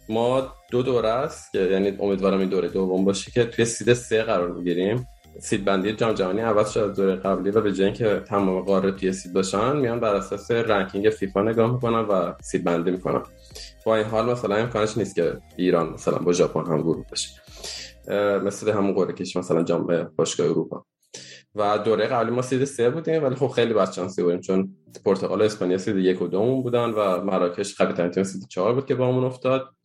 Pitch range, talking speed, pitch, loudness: 95-115 Hz, 200 wpm, 100 Hz, -23 LUFS